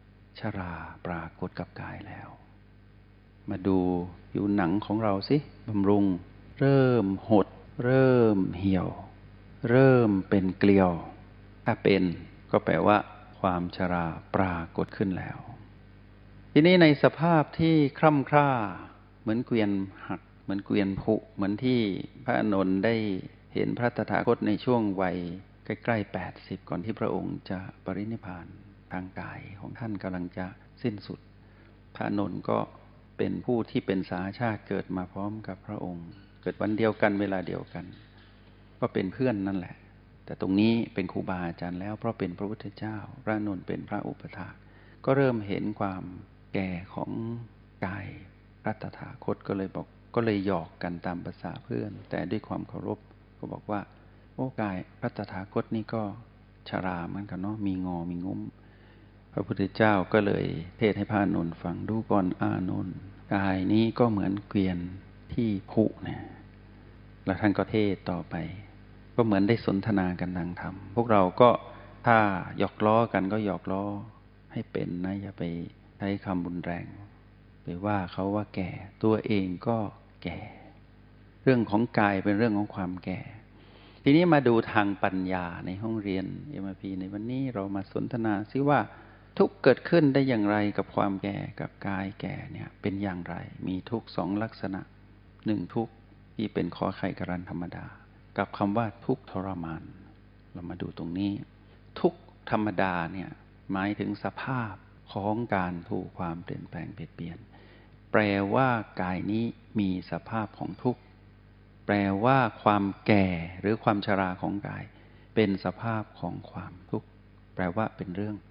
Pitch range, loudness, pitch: 95-110 Hz, -29 LUFS, 100 Hz